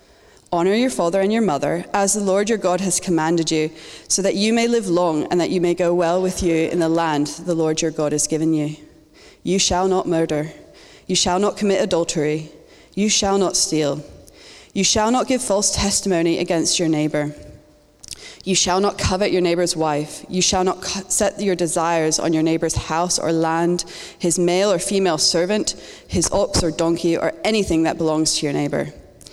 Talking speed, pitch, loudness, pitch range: 195 wpm, 175 Hz, -19 LUFS, 160-190 Hz